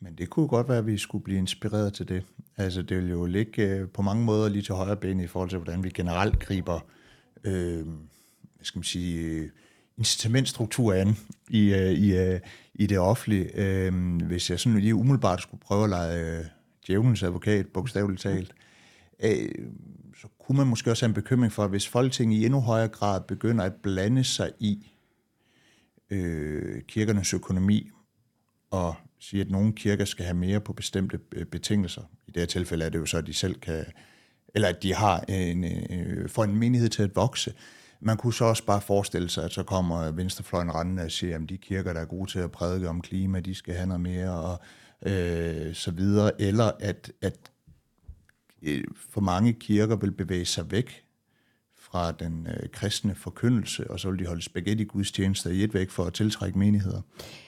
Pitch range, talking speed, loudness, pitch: 90-110 Hz, 185 wpm, -27 LUFS, 95 Hz